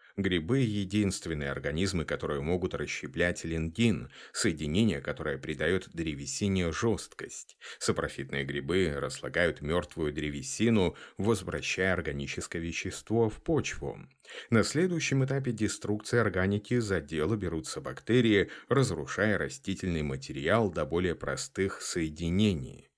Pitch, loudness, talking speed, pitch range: 95 Hz, -31 LUFS, 100 wpm, 80-110 Hz